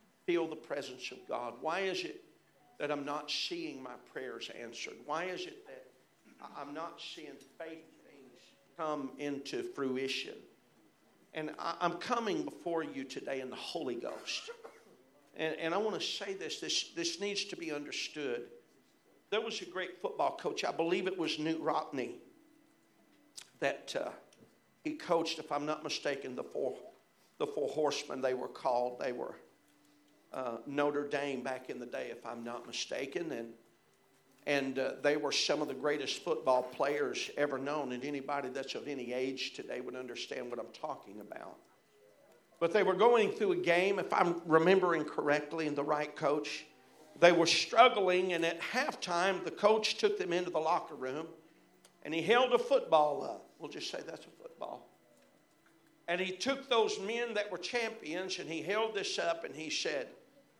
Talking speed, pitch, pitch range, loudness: 170 wpm, 165 Hz, 145-220 Hz, -35 LUFS